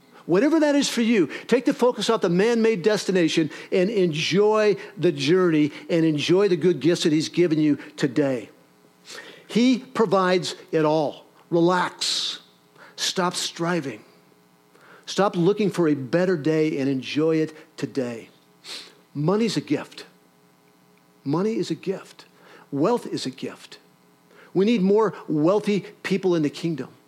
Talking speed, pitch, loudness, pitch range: 135 wpm, 170 Hz, -22 LUFS, 140-195 Hz